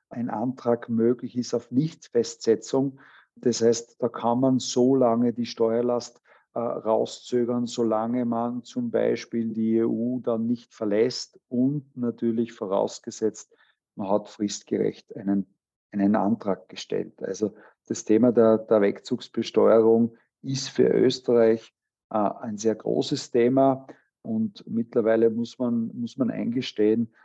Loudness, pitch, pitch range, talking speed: -25 LUFS, 120 Hz, 115-125 Hz, 125 wpm